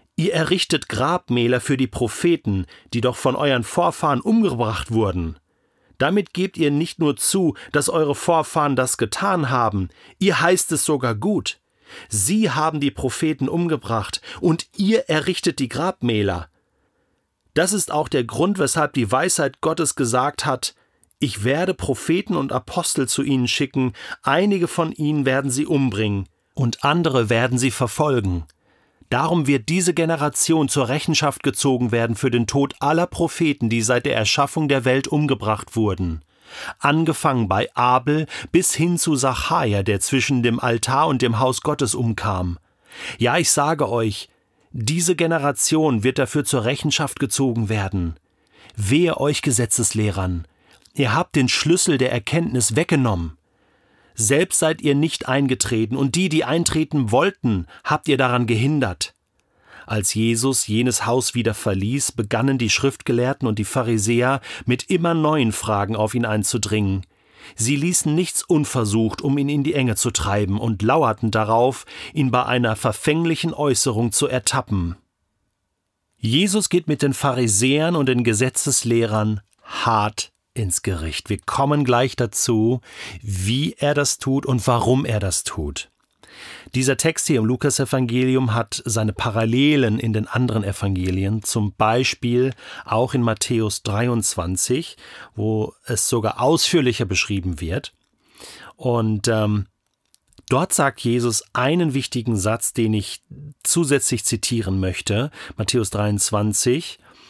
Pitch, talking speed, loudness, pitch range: 125 Hz, 140 wpm, -20 LUFS, 110-150 Hz